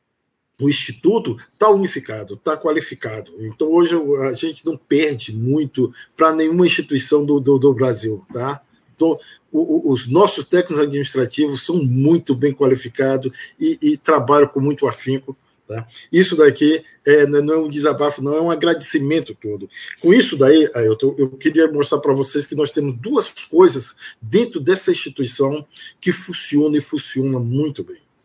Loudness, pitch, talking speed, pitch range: -17 LUFS, 145 Hz, 160 wpm, 135-160 Hz